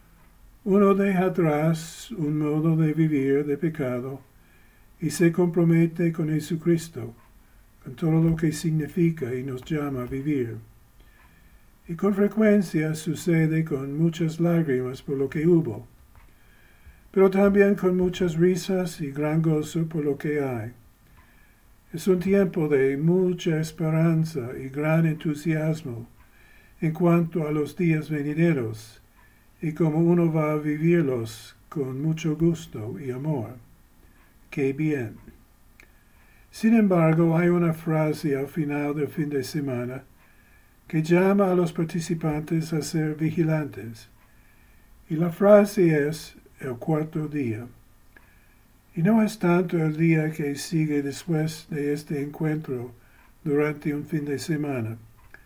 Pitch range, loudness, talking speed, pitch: 125-170 Hz, -24 LUFS, 130 wpm, 155 Hz